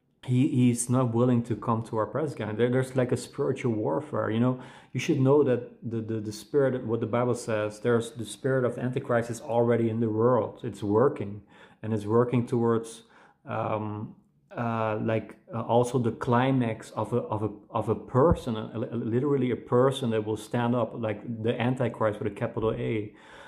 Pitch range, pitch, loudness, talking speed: 110-125 Hz, 115 Hz, -27 LUFS, 190 wpm